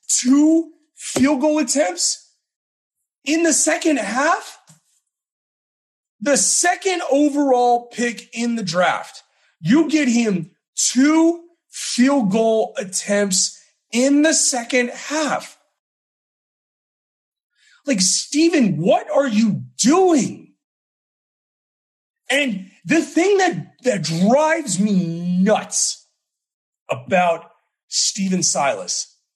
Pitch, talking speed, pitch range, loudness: 255 Hz, 90 wpm, 205-310 Hz, -18 LUFS